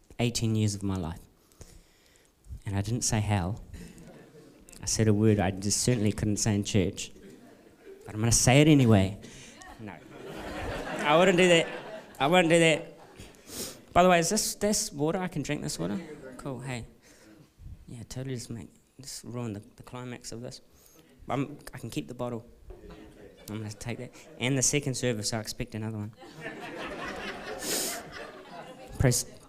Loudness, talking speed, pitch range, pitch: -27 LUFS, 165 wpm, 105-140 Hz, 120 Hz